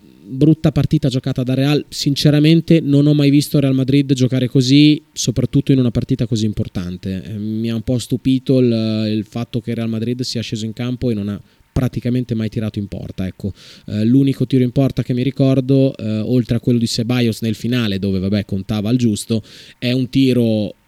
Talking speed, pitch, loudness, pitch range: 195 wpm, 125 Hz, -17 LUFS, 110-135 Hz